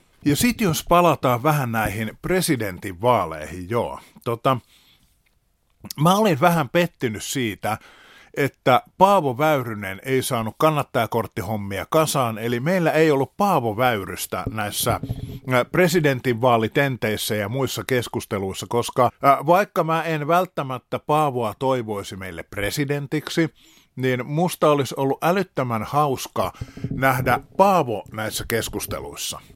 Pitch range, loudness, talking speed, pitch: 110-155 Hz, -22 LUFS, 105 wpm, 130 Hz